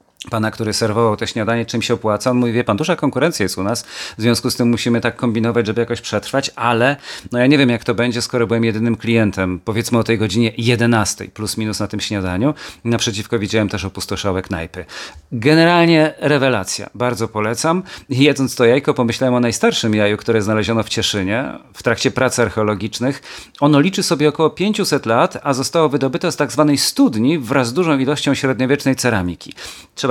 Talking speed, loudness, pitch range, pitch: 180 wpm, -17 LUFS, 110-135 Hz, 120 Hz